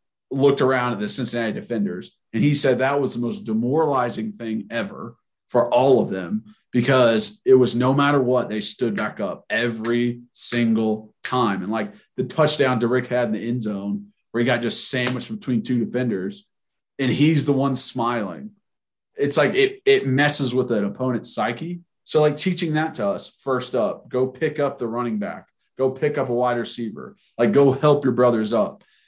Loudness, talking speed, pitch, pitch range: -21 LUFS, 190 wpm, 125 Hz, 120-145 Hz